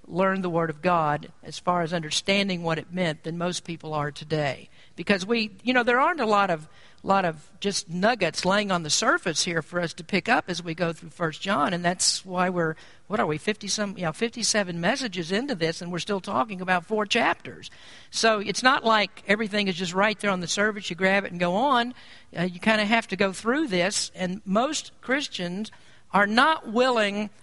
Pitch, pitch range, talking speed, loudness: 190 Hz, 175-215 Hz, 220 wpm, -25 LUFS